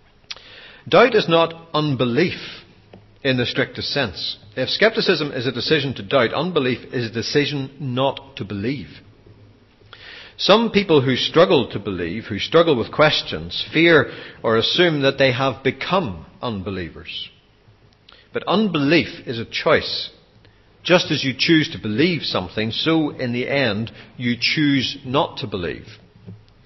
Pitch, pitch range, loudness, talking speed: 130 Hz, 110-150 Hz, -19 LUFS, 135 wpm